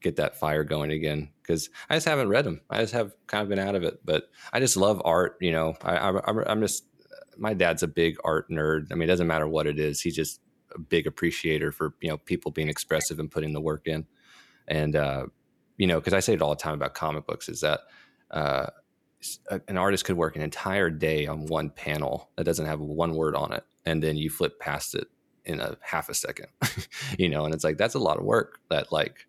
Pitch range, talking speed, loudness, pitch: 75-85 Hz, 245 wpm, -27 LUFS, 80 Hz